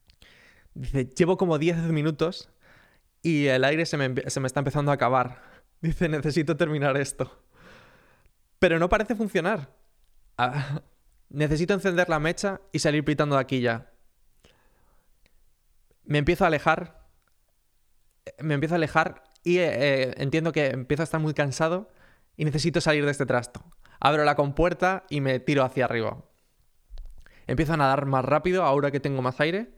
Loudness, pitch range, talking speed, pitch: -25 LUFS, 130-165 Hz, 155 wpm, 150 Hz